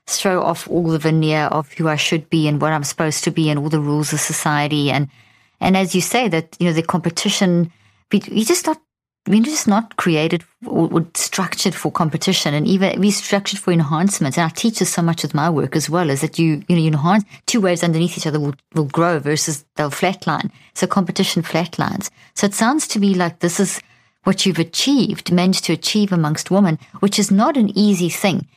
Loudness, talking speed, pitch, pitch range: -18 LUFS, 215 wpm, 175 Hz, 155-195 Hz